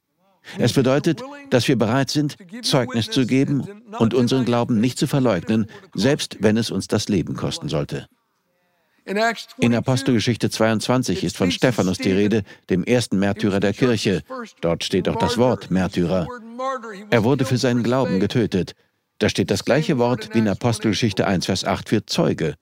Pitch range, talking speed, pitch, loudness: 110-150 Hz, 160 wpm, 125 Hz, -21 LUFS